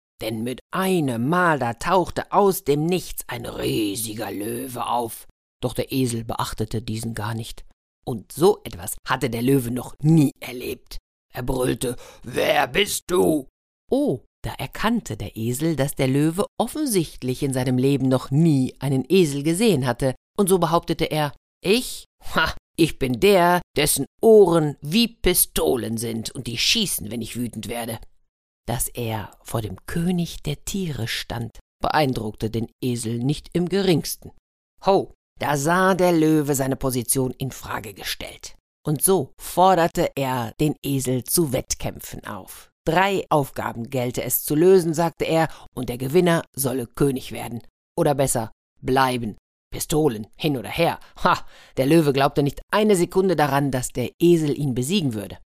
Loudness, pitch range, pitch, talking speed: -22 LUFS, 120-170 Hz, 135 Hz, 155 wpm